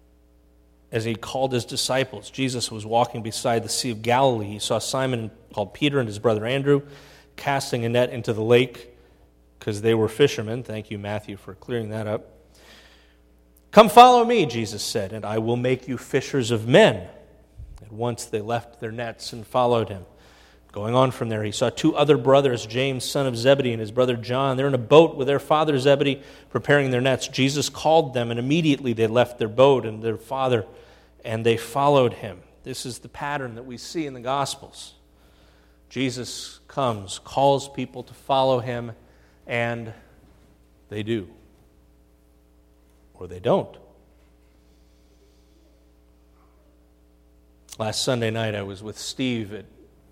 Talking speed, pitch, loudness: 165 wpm, 115 Hz, -22 LUFS